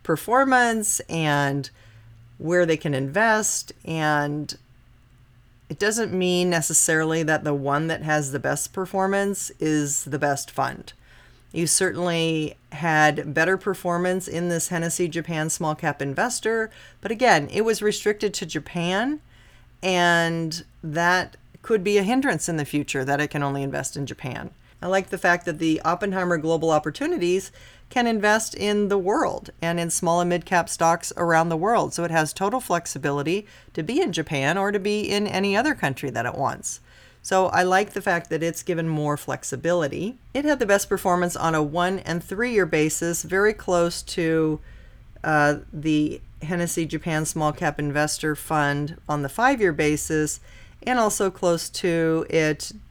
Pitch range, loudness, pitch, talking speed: 150-190 Hz, -23 LUFS, 165 Hz, 165 wpm